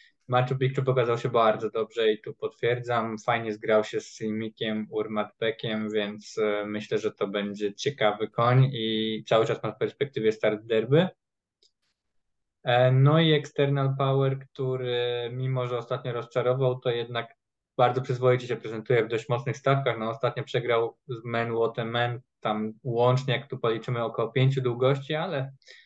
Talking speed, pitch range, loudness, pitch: 150 wpm, 110-130 Hz, -27 LUFS, 120 Hz